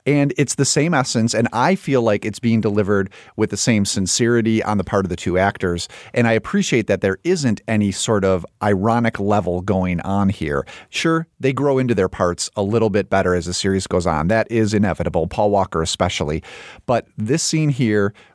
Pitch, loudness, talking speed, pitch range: 105 Hz, -19 LUFS, 205 wpm, 95-120 Hz